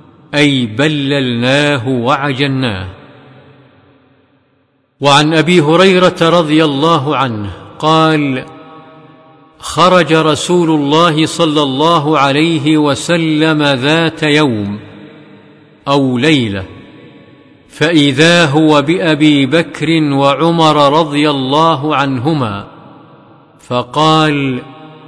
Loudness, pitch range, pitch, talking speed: -11 LUFS, 140-160 Hz, 150 Hz, 70 wpm